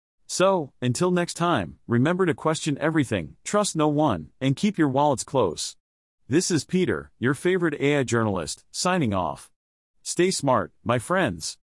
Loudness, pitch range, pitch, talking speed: -24 LUFS, 125-175 Hz, 150 Hz, 150 wpm